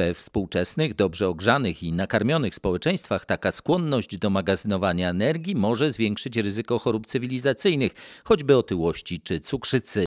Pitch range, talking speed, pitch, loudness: 95-130 Hz, 125 wpm, 110 Hz, -24 LUFS